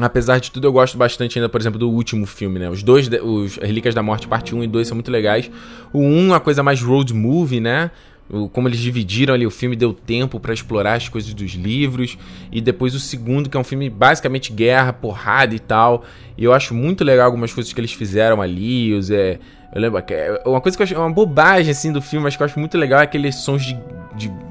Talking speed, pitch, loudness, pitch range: 245 wpm, 120 Hz, -17 LUFS, 110-135 Hz